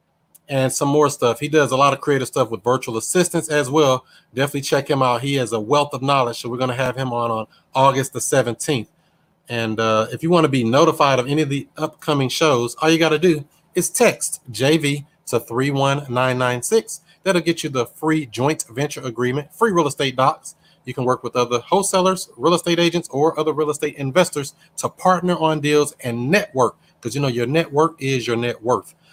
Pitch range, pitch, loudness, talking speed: 125-160 Hz, 140 Hz, -19 LUFS, 210 wpm